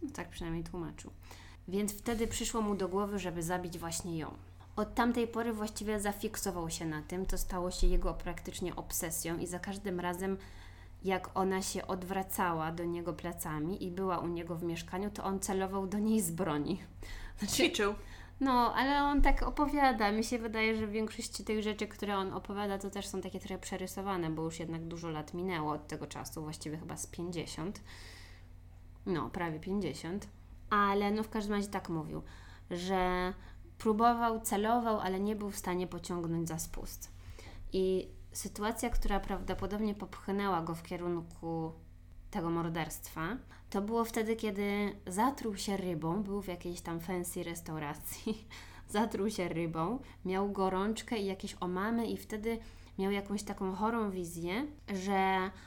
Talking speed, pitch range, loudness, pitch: 160 wpm, 165-205 Hz, -36 LUFS, 185 Hz